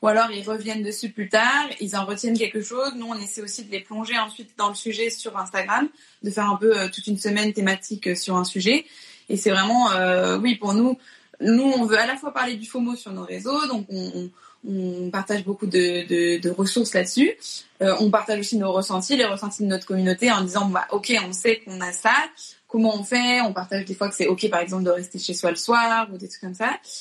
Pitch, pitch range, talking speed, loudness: 210 Hz, 190-230 Hz, 245 wpm, -23 LUFS